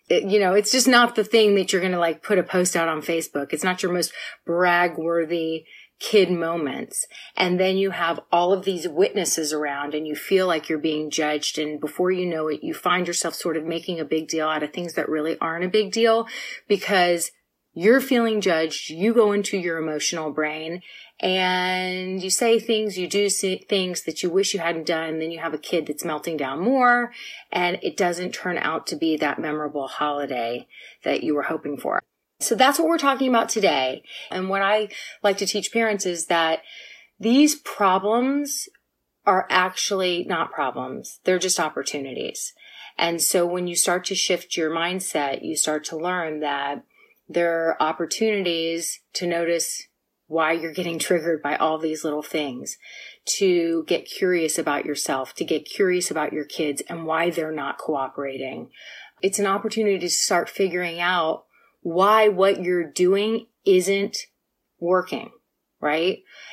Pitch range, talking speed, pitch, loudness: 160-195 Hz, 180 wpm, 175 Hz, -23 LUFS